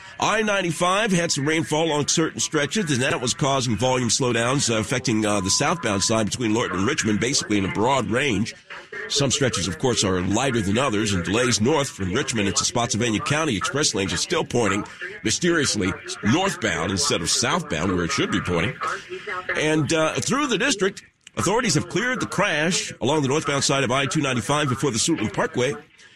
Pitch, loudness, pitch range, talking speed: 140 Hz, -22 LUFS, 115-160 Hz, 180 wpm